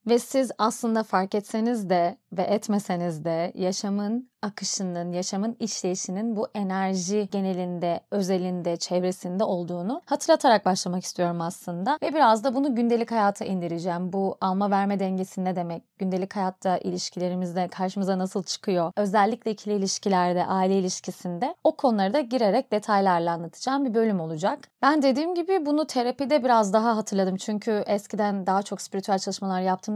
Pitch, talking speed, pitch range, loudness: 200 Hz, 140 wpm, 185-225 Hz, -26 LUFS